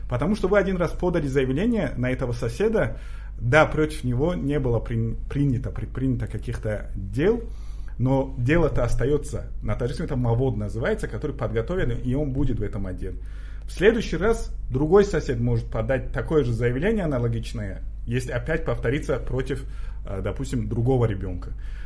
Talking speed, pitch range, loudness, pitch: 145 wpm, 115-150 Hz, -25 LUFS, 125 Hz